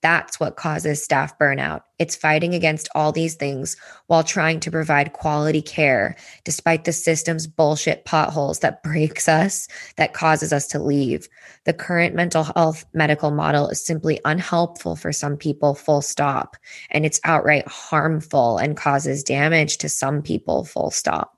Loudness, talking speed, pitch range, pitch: -20 LUFS, 155 wpm, 145-160 Hz, 155 Hz